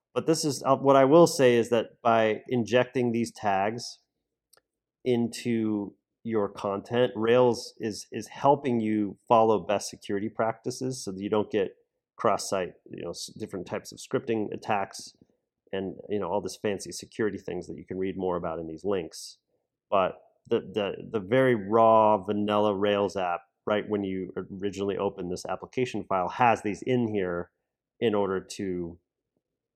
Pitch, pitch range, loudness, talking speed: 105 Hz, 100-125 Hz, -27 LUFS, 165 wpm